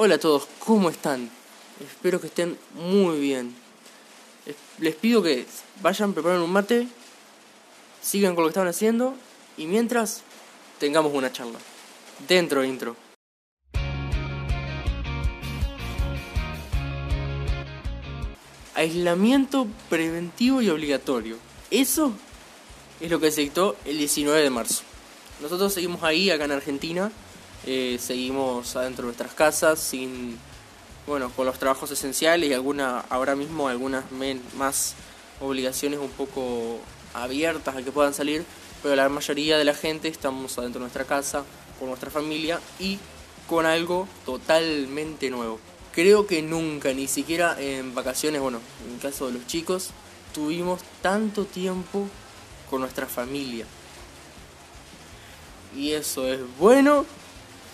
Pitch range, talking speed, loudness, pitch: 125-170 Hz, 120 wpm, -25 LUFS, 140 Hz